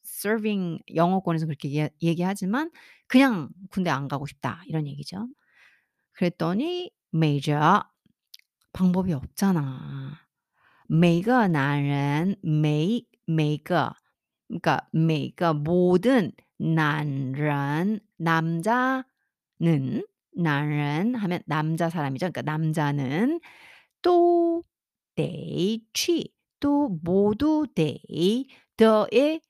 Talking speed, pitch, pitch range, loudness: 170 characters per minute, 175 Hz, 155-230 Hz, -25 LUFS